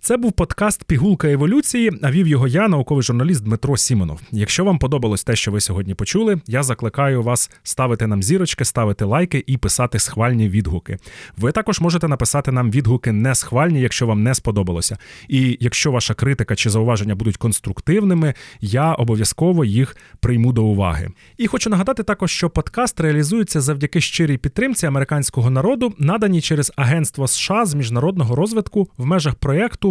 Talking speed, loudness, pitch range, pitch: 165 wpm, -18 LUFS, 115-170 Hz, 140 Hz